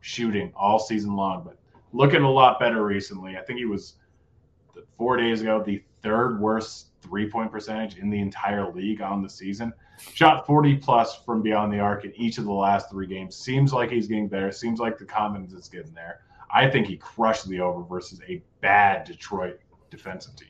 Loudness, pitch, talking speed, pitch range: -24 LUFS, 105 Hz, 195 wpm, 100-115 Hz